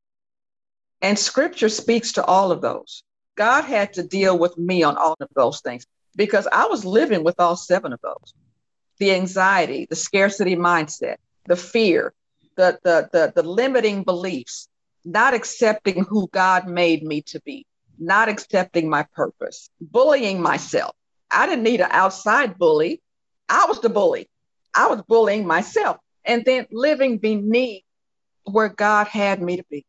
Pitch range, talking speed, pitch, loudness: 175-230 Hz, 155 wpm, 195 Hz, -19 LUFS